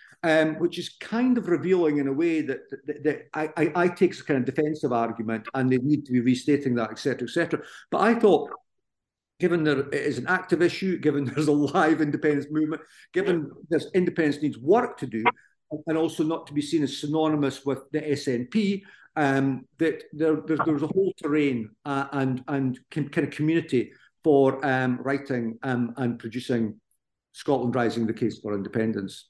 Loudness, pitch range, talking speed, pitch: -25 LUFS, 130-160 Hz, 185 wpm, 150 Hz